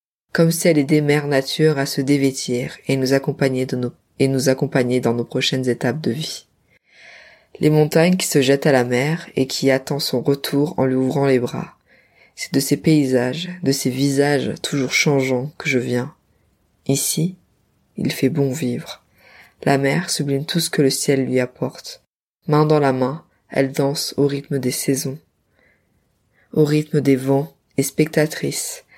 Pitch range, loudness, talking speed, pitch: 130-150 Hz, -19 LUFS, 175 wpm, 140 Hz